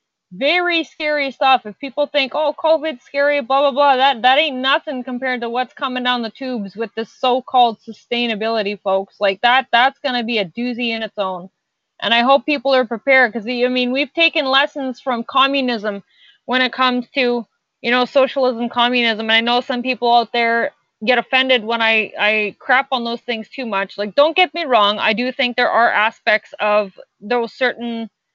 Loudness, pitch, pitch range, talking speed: -17 LUFS, 250 Hz, 230-270 Hz, 195 wpm